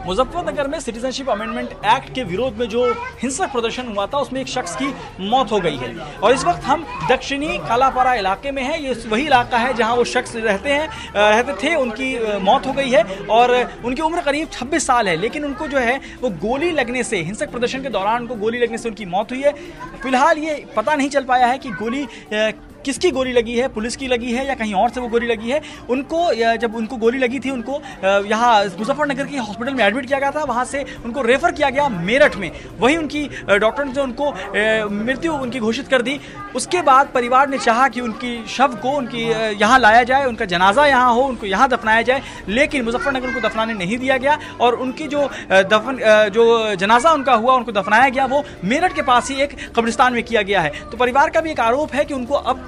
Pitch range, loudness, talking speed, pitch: 230-275 Hz, -18 LUFS, 220 wpm, 255 Hz